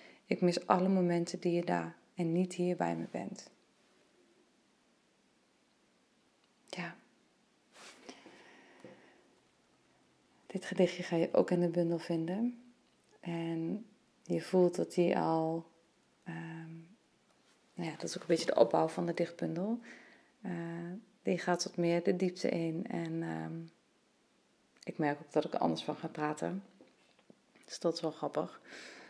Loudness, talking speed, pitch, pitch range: -35 LUFS, 140 wpm, 170 Hz, 160-180 Hz